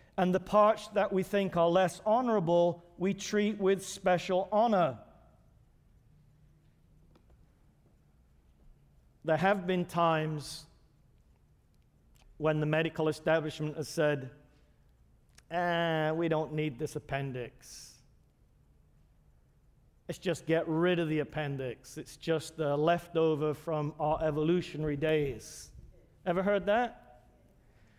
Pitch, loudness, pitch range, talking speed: 155 Hz, -31 LUFS, 145-175 Hz, 105 wpm